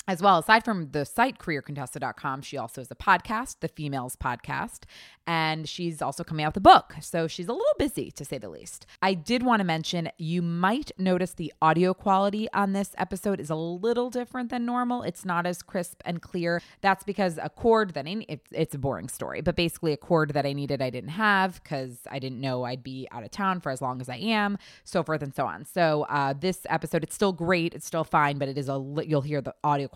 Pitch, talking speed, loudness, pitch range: 170 Hz, 240 wpm, -27 LUFS, 145-195 Hz